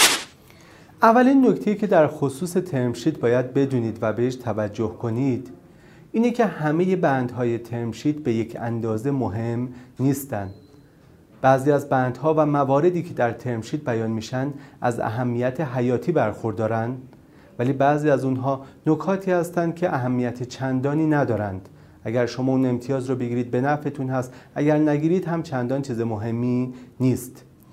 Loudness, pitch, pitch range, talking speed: -23 LUFS, 130 Hz, 120-150 Hz, 135 wpm